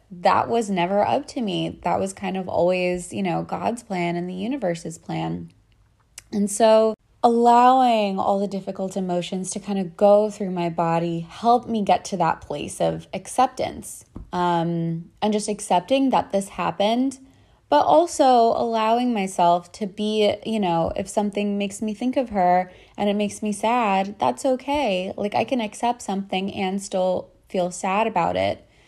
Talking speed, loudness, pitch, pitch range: 170 wpm, -22 LUFS, 200 Hz, 180-225 Hz